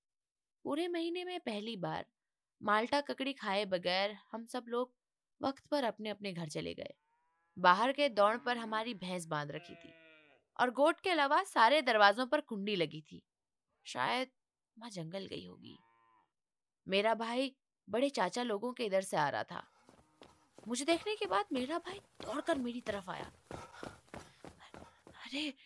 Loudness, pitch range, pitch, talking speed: -35 LUFS, 195-280 Hz, 230 Hz, 150 wpm